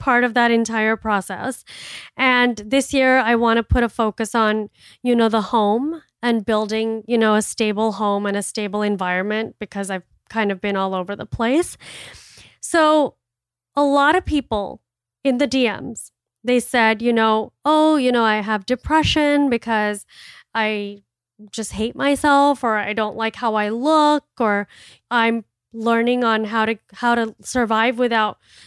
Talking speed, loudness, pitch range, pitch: 165 wpm, -19 LUFS, 210-245 Hz, 225 Hz